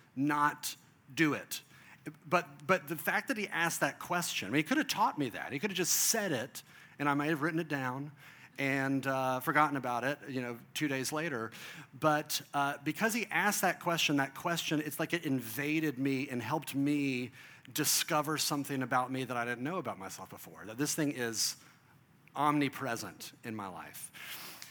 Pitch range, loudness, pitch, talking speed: 135-160 Hz, -33 LUFS, 145 Hz, 190 wpm